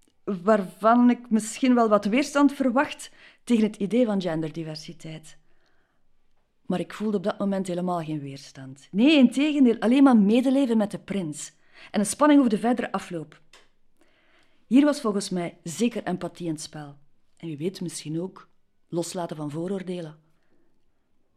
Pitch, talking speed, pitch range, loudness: 195 Hz, 150 wpm, 170-240 Hz, -24 LUFS